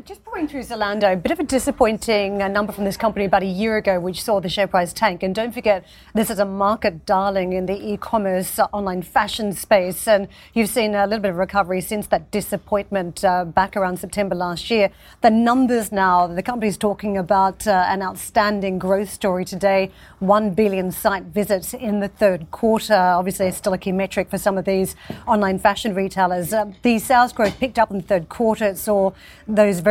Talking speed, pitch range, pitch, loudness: 210 wpm, 190-215 Hz, 200 Hz, -20 LUFS